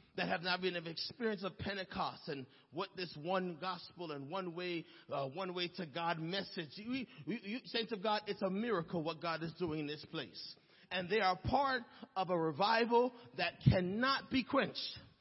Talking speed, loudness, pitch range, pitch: 195 wpm, -38 LUFS, 170-215 Hz, 185 Hz